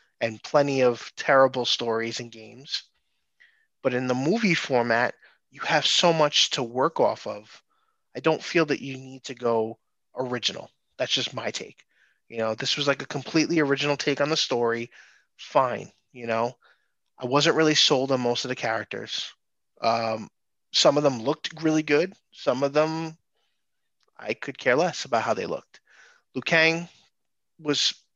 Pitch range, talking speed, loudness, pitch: 120-155 Hz, 165 wpm, -24 LUFS, 135 Hz